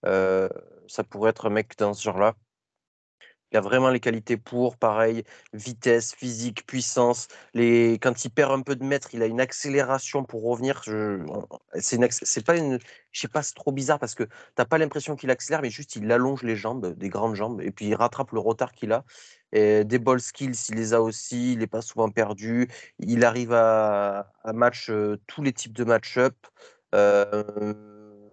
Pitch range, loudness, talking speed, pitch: 110-130 Hz, -25 LUFS, 200 wpm, 120 Hz